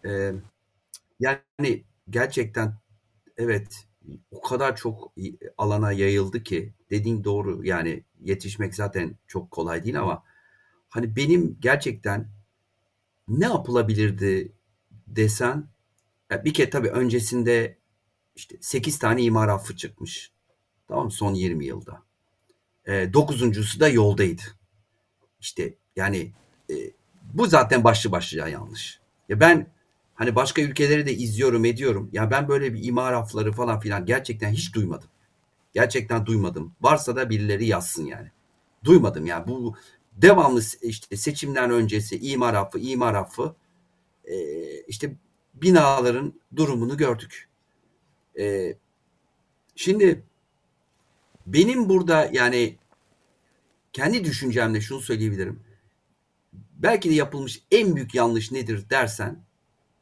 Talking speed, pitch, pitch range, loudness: 115 wpm, 115 Hz, 105-130 Hz, -23 LUFS